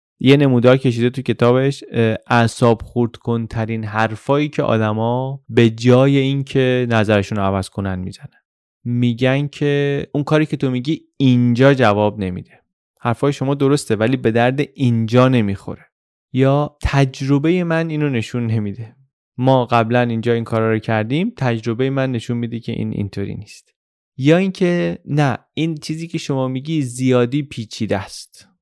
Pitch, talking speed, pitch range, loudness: 125 Hz, 145 wpm, 115-140 Hz, -17 LUFS